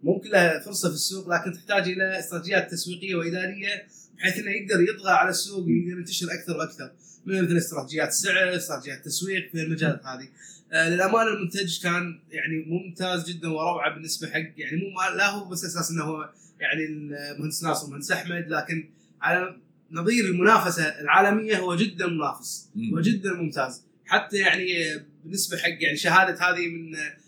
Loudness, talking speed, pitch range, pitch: -25 LUFS, 155 wpm, 160-190 Hz, 175 Hz